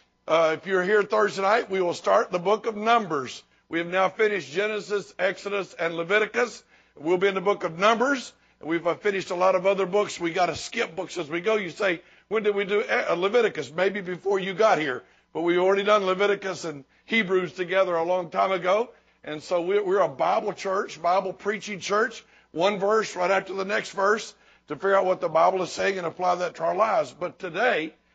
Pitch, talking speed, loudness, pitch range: 195 Hz, 210 wpm, -25 LUFS, 180-210 Hz